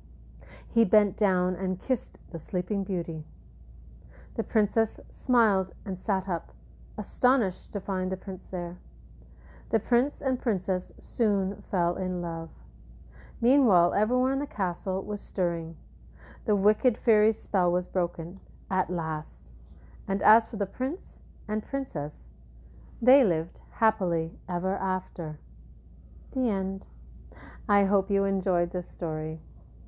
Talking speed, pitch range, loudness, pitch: 125 wpm, 165-215 Hz, -28 LUFS, 185 Hz